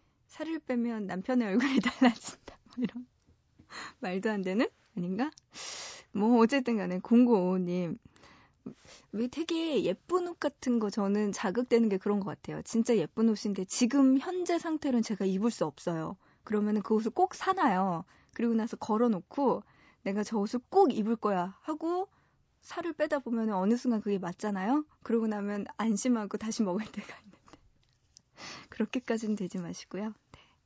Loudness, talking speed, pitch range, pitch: -31 LUFS, 305 characters per minute, 205-255 Hz, 225 Hz